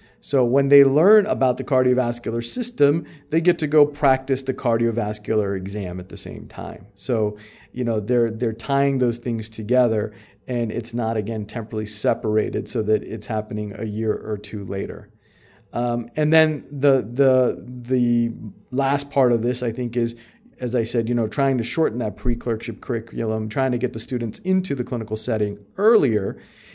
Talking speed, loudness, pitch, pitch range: 175 wpm, -22 LUFS, 120 Hz, 110-135 Hz